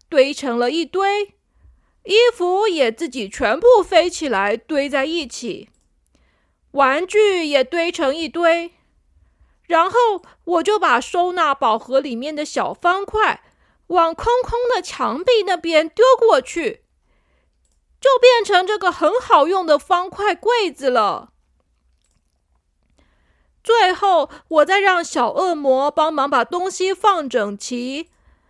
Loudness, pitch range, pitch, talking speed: -17 LUFS, 270-395 Hz, 335 Hz, 175 characters per minute